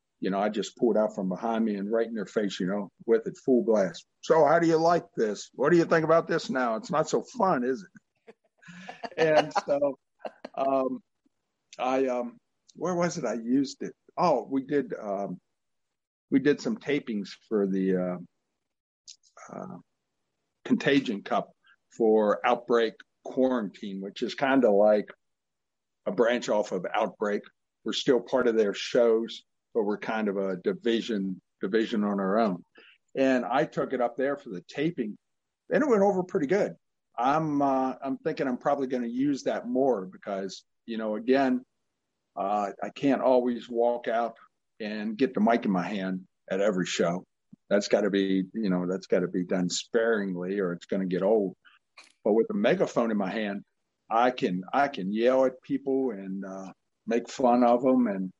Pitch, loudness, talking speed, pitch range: 120 Hz, -27 LUFS, 185 wpm, 100-135 Hz